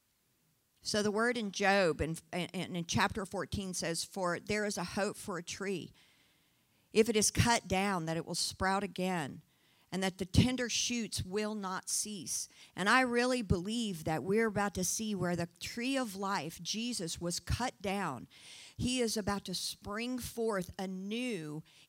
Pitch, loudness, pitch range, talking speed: 195 Hz, -34 LUFS, 175-215 Hz, 170 wpm